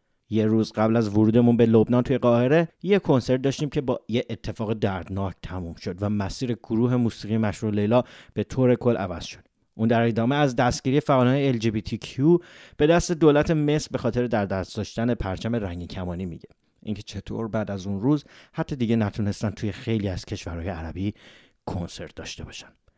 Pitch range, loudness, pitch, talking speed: 105-130 Hz, -24 LUFS, 115 Hz, 185 wpm